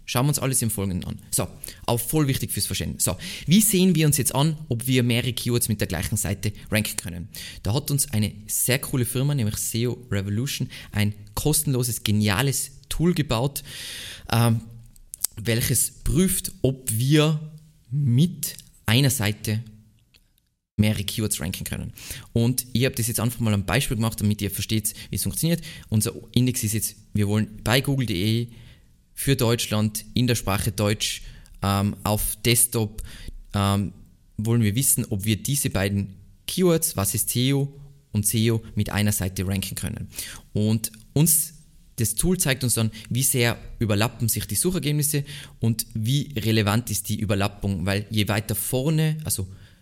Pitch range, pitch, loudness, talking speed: 105-130 Hz, 115 Hz, -24 LUFS, 160 wpm